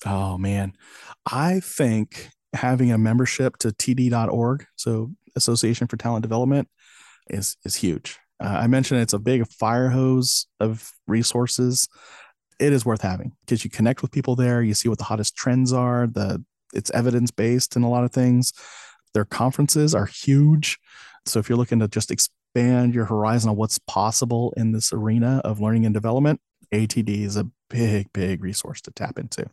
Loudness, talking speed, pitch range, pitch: -22 LUFS, 175 wpm, 110-125 Hz, 120 Hz